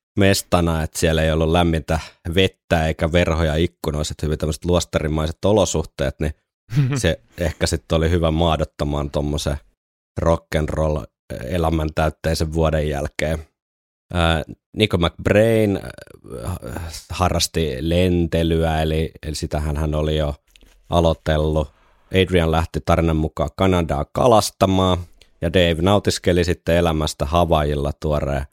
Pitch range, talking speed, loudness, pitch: 75-90 Hz, 105 wpm, -20 LUFS, 80 Hz